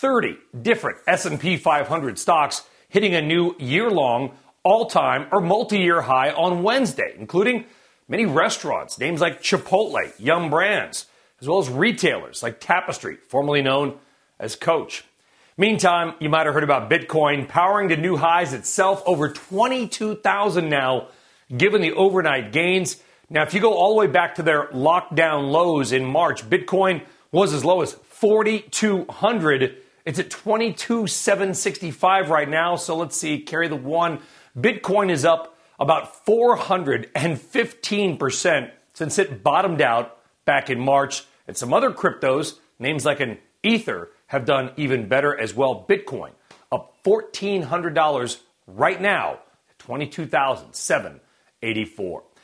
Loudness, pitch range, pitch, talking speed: -21 LUFS, 145-200 Hz, 170 Hz, 135 wpm